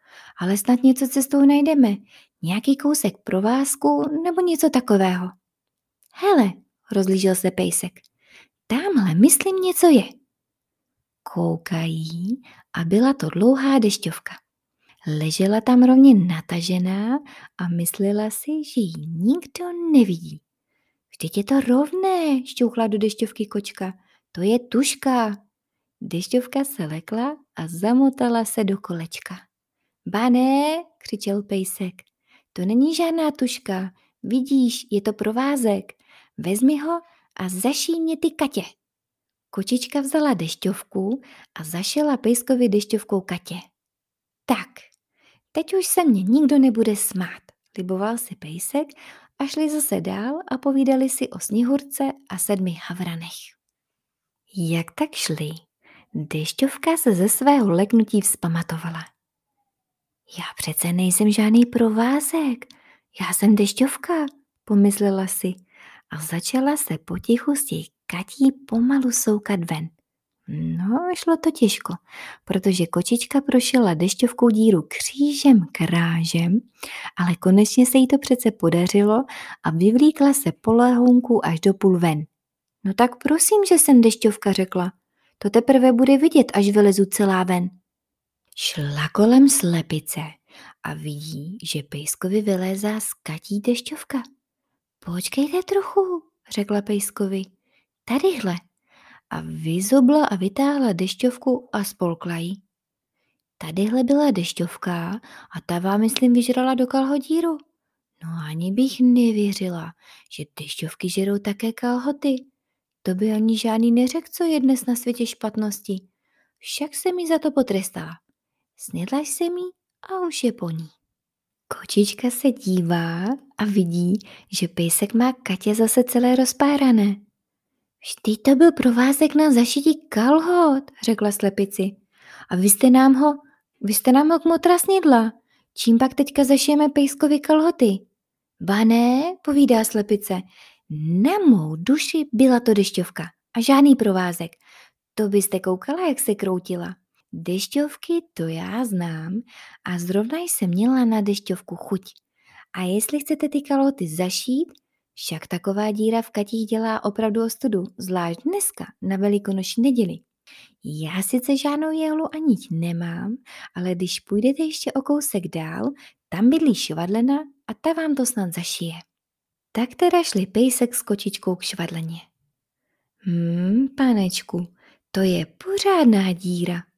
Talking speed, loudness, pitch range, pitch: 125 wpm, -20 LUFS, 185-270 Hz, 220 Hz